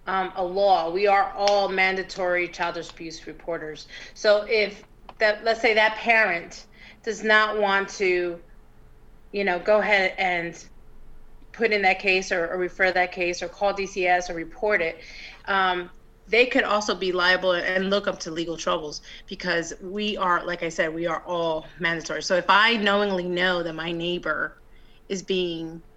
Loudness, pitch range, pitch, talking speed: -23 LUFS, 175-205 Hz, 185 Hz, 170 wpm